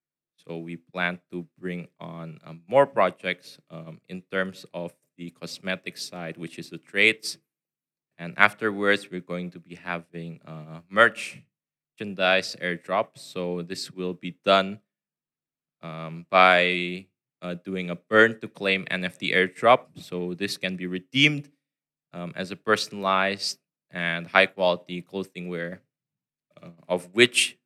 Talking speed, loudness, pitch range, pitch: 135 wpm, -24 LUFS, 85-100 Hz, 90 Hz